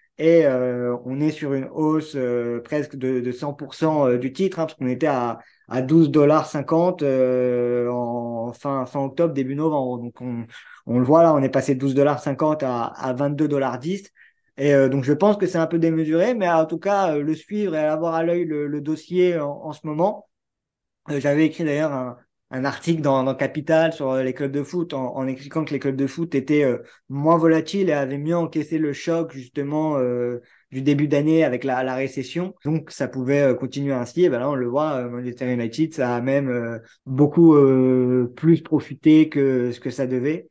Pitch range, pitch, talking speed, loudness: 130-160 Hz, 145 Hz, 205 wpm, -21 LUFS